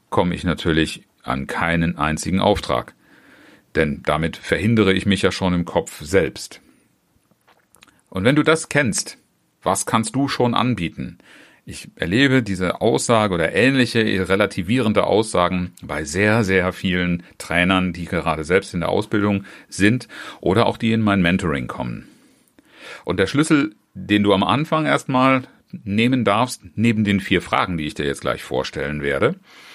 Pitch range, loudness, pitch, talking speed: 85-115 Hz, -19 LUFS, 100 Hz, 150 wpm